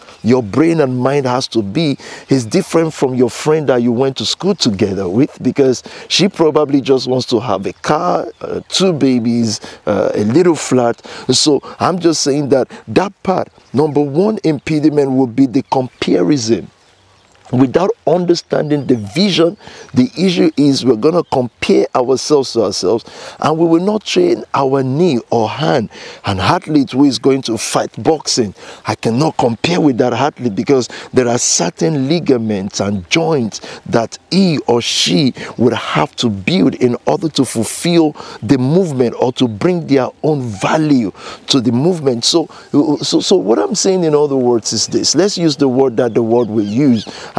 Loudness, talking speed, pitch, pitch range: -14 LUFS, 170 wpm, 135 Hz, 125-160 Hz